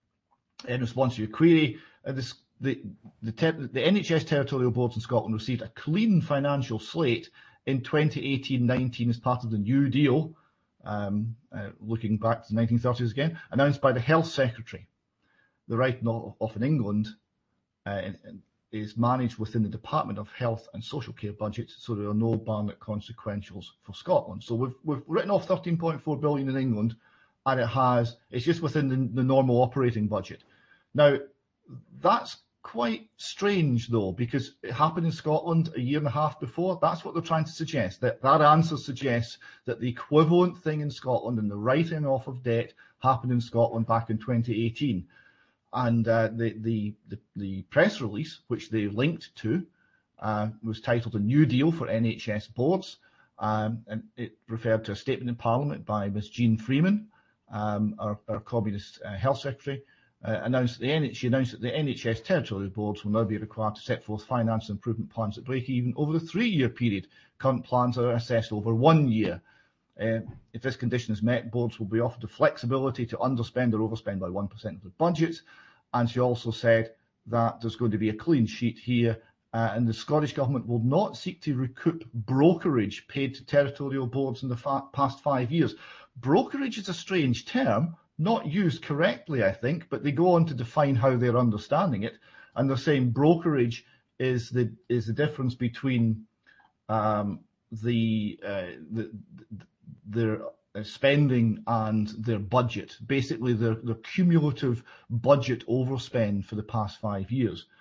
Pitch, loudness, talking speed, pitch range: 120 Hz, -27 LUFS, 180 wpm, 110-140 Hz